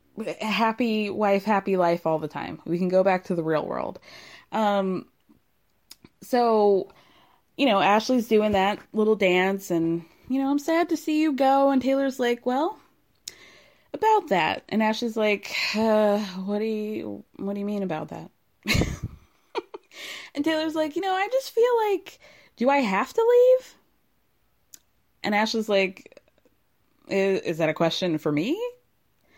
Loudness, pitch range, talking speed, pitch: -24 LUFS, 190-280 Hz, 155 wpm, 215 Hz